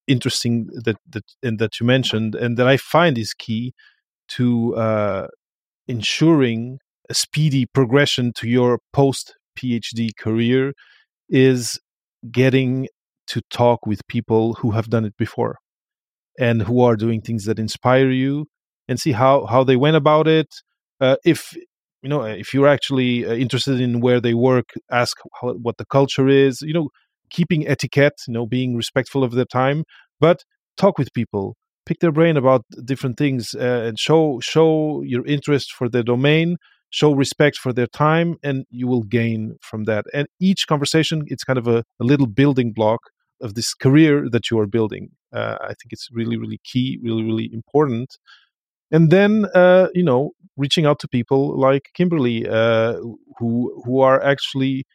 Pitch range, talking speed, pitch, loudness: 115-145 Hz, 170 wpm, 130 Hz, -19 LUFS